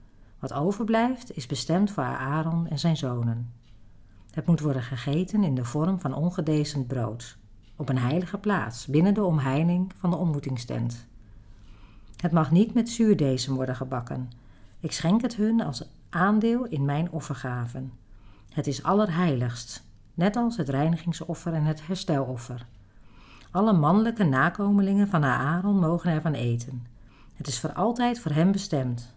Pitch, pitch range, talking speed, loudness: 150 Hz, 120-180 Hz, 145 wpm, -26 LUFS